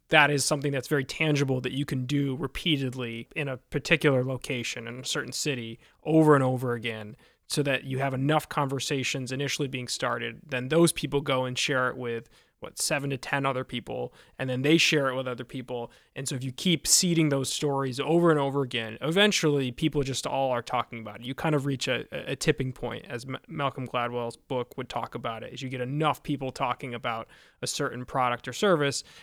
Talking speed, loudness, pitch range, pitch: 210 wpm, -27 LUFS, 125-145 Hz, 135 Hz